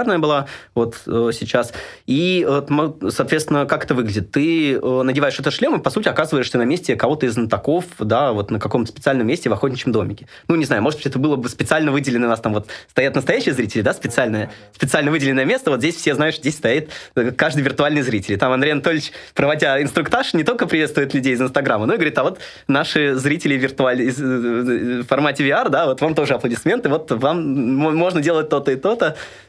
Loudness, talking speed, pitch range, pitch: -18 LUFS, 195 wpm, 120-150 Hz, 140 Hz